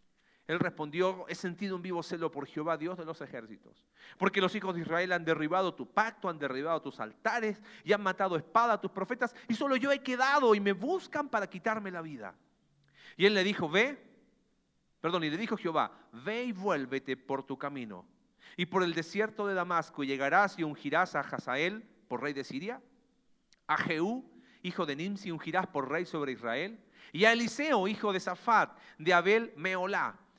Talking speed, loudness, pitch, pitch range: 190 wpm, -32 LUFS, 185 Hz, 165-220 Hz